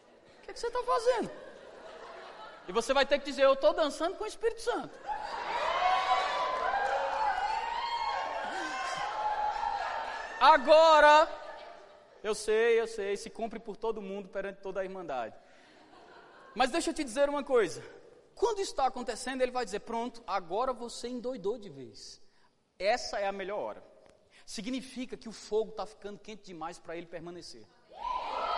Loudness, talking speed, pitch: -30 LUFS, 140 wpm, 280 Hz